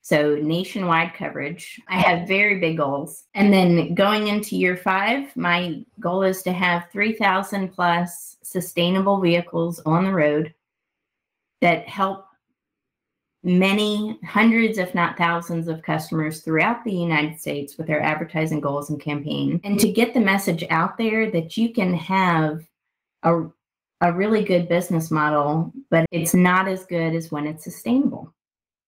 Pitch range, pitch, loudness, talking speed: 165-195 Hz, 175 Hz, -21 LUFS, 150 wpm